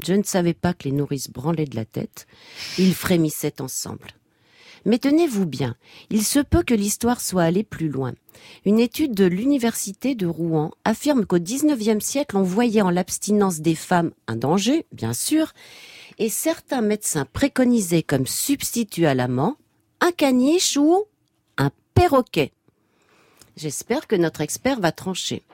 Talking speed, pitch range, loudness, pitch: 155 wpm, 155-245 Hz, -21 LUFS, 195 Hz